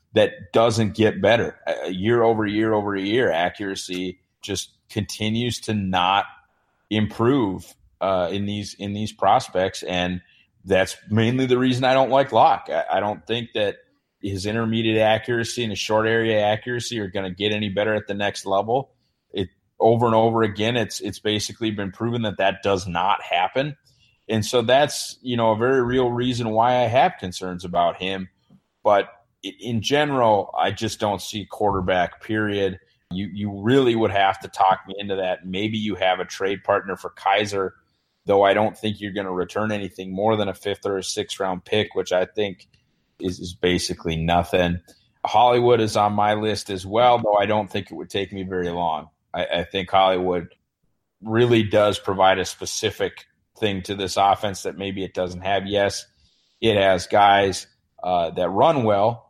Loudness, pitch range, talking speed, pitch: -22 LUFS, 95-110 Hz, 180 wpm, 105 Hz